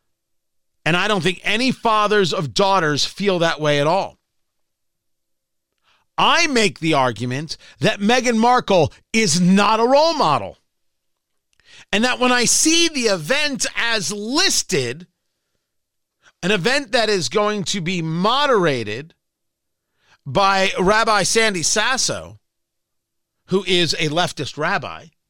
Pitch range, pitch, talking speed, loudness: 175-230 Hz, 200 Hz, 120 wpm, -17 LUFS